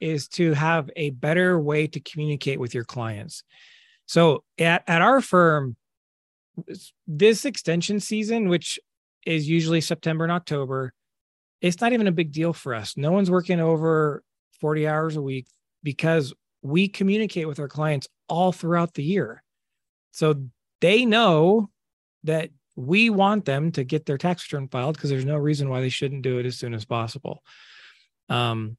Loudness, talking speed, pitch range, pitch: -23 LUFS, 165 wpm, 140-175 Hz, 155 Hz